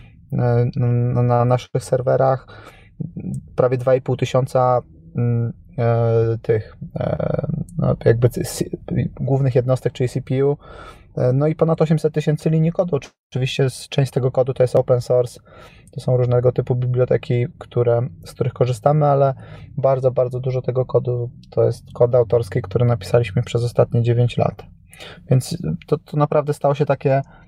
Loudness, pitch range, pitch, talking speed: -19 LUFS, 120-140 Hz, 125 Hz, 130 wpm